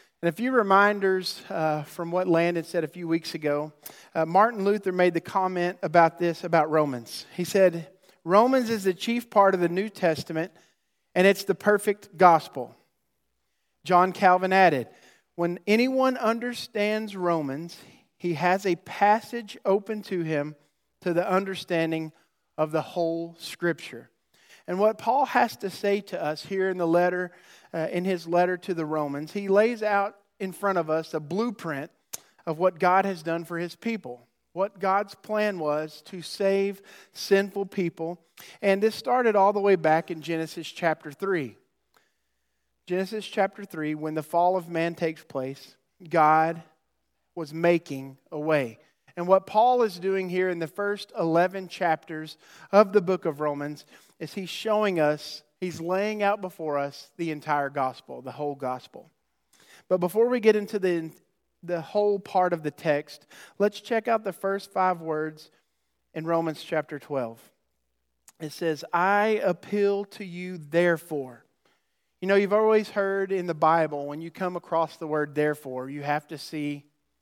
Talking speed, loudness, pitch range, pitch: 165 wpm, -26 LUFS, 155-195 Hz, 175 Hz